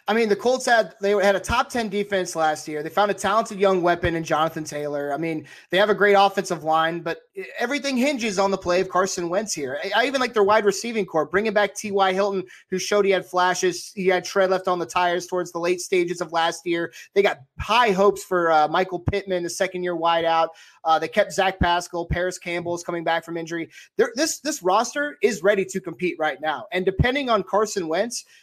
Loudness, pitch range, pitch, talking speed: -22 LUFS, 170-205 Hz, 185 Hz, 230 wpm